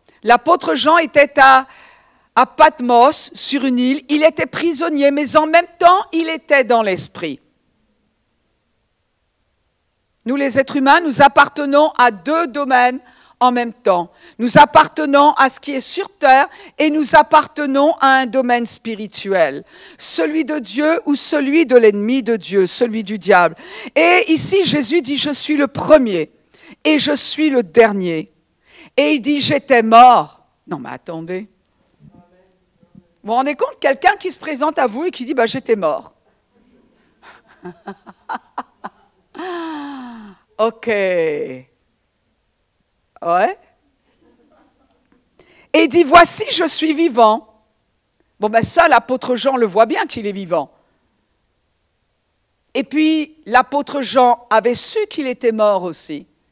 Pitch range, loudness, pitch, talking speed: 215-305 Hz, -14 LUFS, 265 Hz, 135 wpm